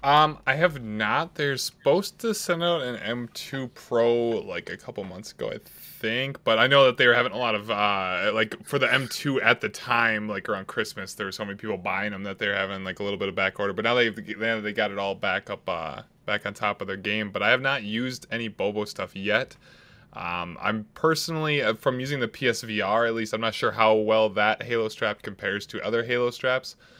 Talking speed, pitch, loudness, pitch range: 235 wpm, 115 Hz, -25 LUFS, 105-130 Hz